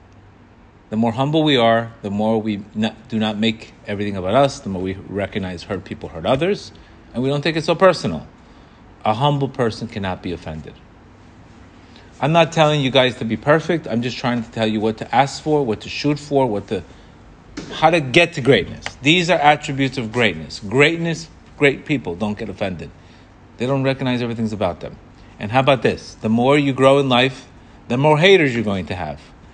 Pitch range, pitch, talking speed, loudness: 105-140 Hz, 120 Hz, 200 wpm, -18 LUFS